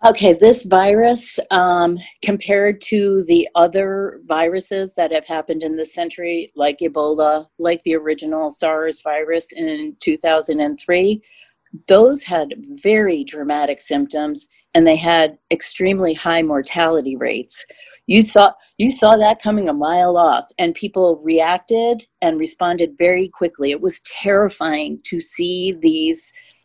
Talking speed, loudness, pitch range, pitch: 135 wpm, -17 LUFS, 160-210 Hz, 180 Hz